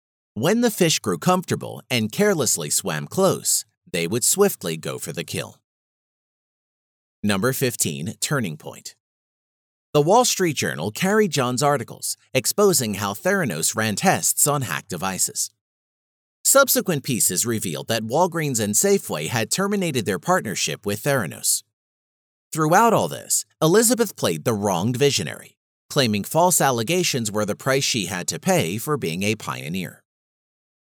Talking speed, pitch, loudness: 135 wpm, 130 Hz, -21 LUFS